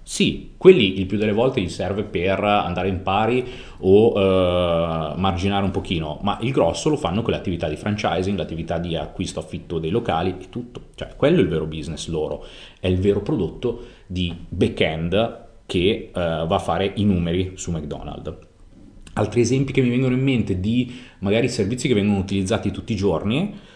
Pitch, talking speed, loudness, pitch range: 95 Hz, 185 wpm, -21 LUFS, 85-110 Hz